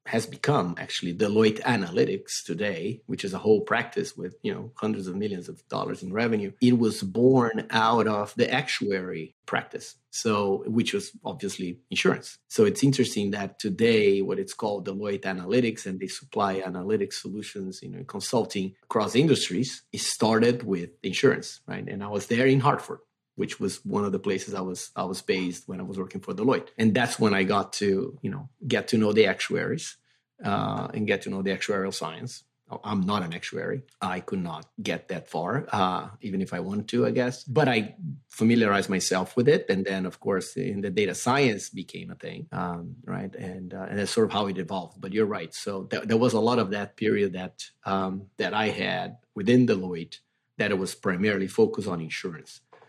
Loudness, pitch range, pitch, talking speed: -27 LUFS, 95-125 Hz, 105 Hz, 200 wpm